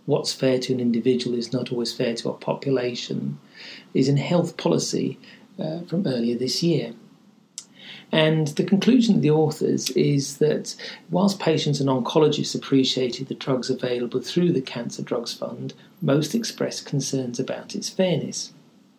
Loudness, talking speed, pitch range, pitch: -23 LUFS, 150 wpm, 125-180 Hz, 140 Hz